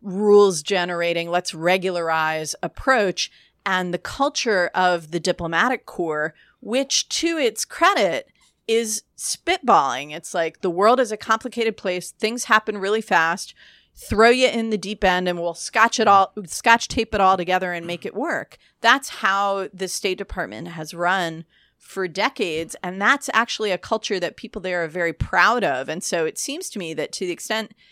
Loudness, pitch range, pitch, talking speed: -21 LUFS, 175-225 Hz, 190 Hz, 175 wpm